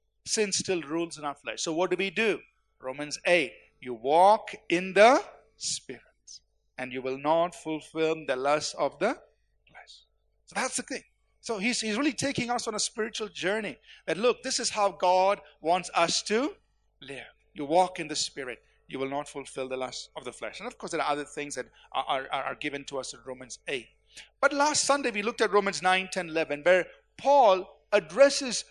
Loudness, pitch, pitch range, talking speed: -27 LUFS, 180 Hz, 145-220 Hz, 200 wpm